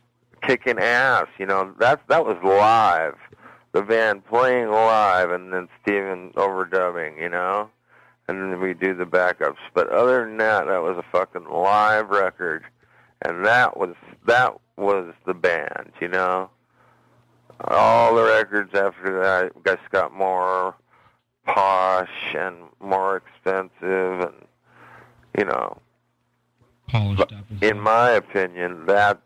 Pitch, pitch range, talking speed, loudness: 95 Hz, 95-110 Hz, 130 wpm, -21 LUFS